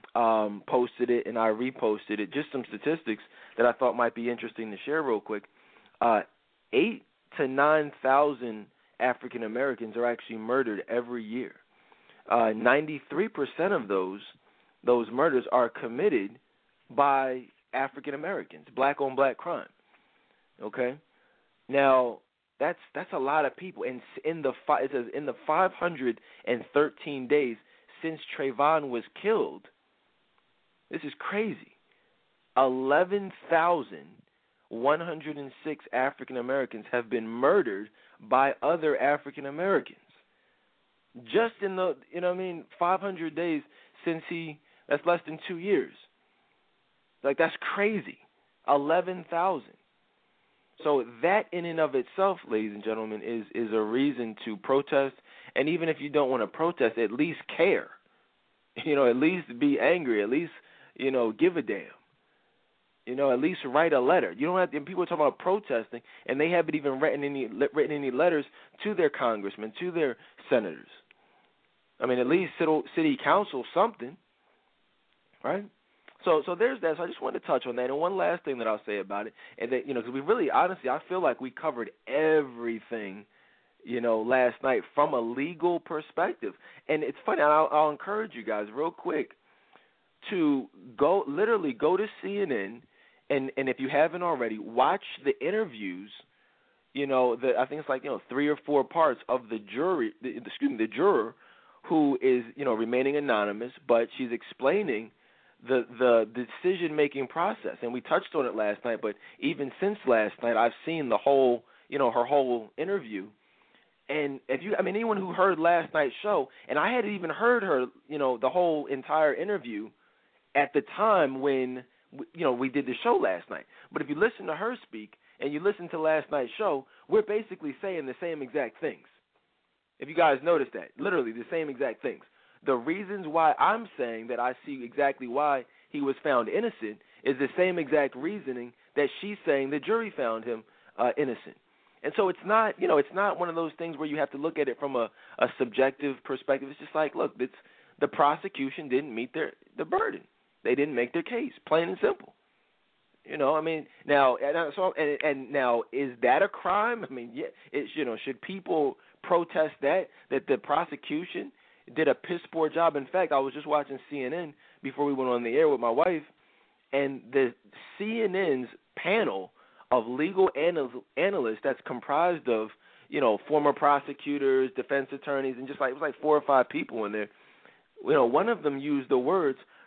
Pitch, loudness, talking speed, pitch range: 145 Hz, -28 LUFS, 180 wpm, 125-175 Hz